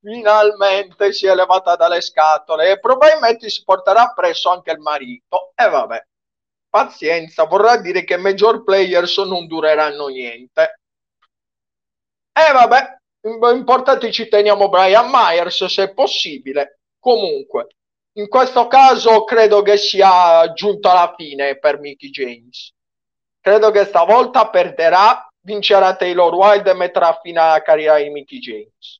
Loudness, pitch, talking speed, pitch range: -13 LUFS, 190 Hz, 135 wpm, 165-220 Hz